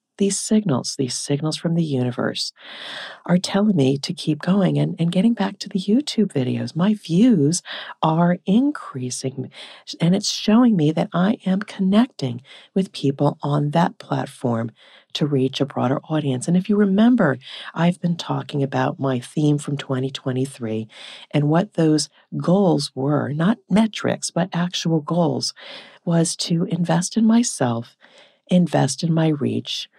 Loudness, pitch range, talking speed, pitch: -21 LUFS, 140-195 Hz, 150 wpm, 165 Hz